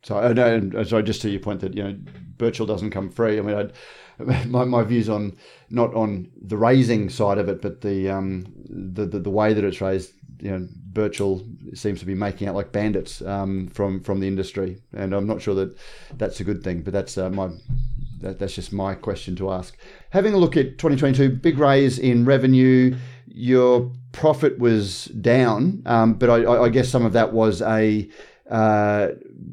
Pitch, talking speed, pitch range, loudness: 105 Hz, 200 wpm, 95-120 Hz, -21 LUFS